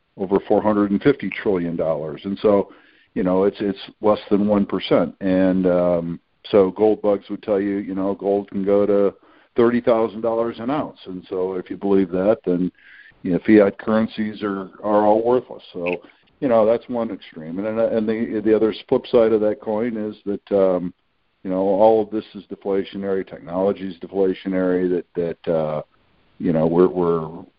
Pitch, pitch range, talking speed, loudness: 100 Hz, 95-105 Hz, 190 wpm, -20 LUFS